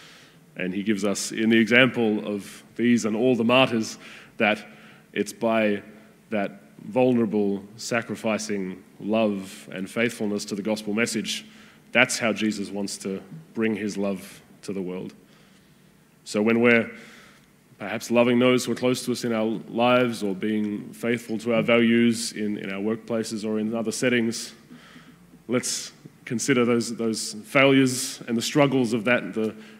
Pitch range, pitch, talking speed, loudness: 105-120 Hz, 110 Hz, 150 wpm, -24 LUFS